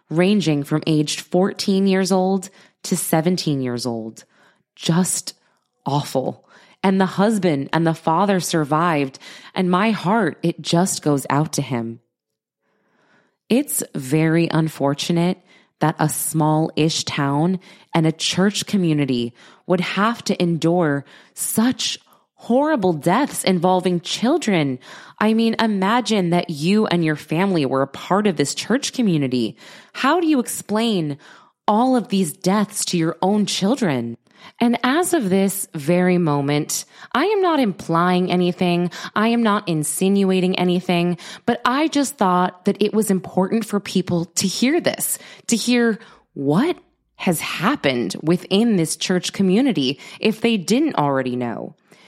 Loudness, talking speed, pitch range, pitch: -20 LUFS, 135 wpm, 160-205 Hz, 180 Hz